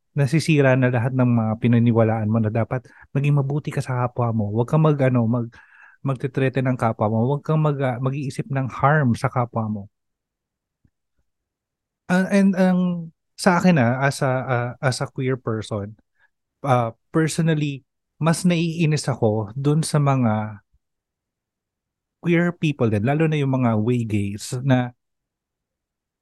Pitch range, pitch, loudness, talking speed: 115-150 Hz, 130 Hz, -21 LUFS, 150 wpm